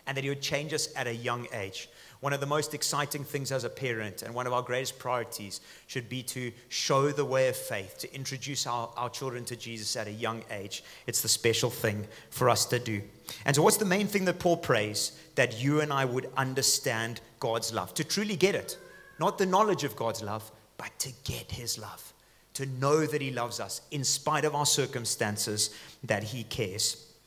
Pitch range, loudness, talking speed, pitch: 115-140 Hz, -30 LUFS, 215 wpm, 125 Hz